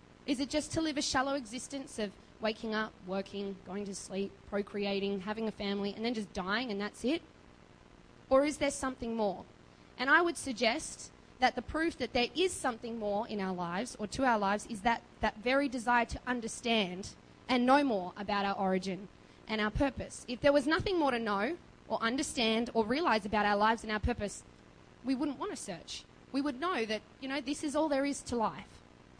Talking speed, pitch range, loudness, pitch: 210 wpm, 205-275 Hz, -33 LUFS, 230 Hz